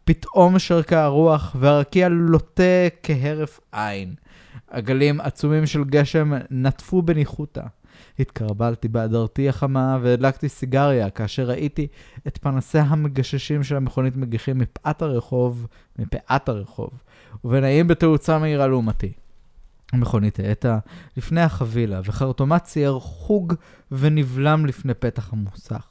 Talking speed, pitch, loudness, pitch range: 105 wpm, 135 Hz, -21 LUFS, 120-150 Hz